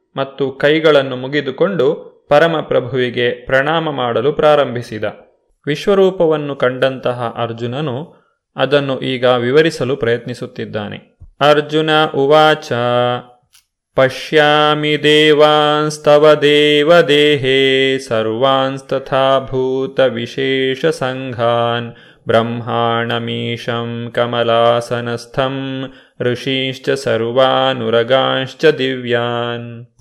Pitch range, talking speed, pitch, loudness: 120-150 Hz, 55 wpm, 130 Hz, -14 LUFS